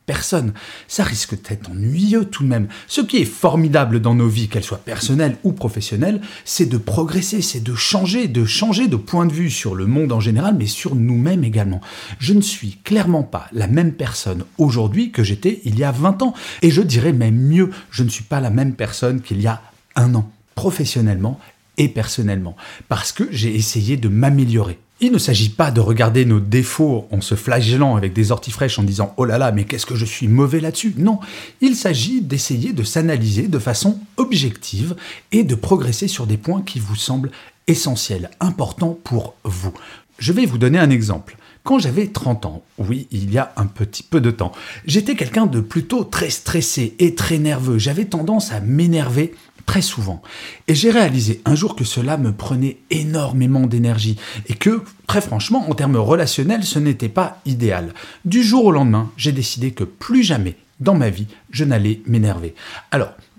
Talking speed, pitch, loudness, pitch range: 195 wpm, 125 Hz, -18 LUFS, 110-165 Hz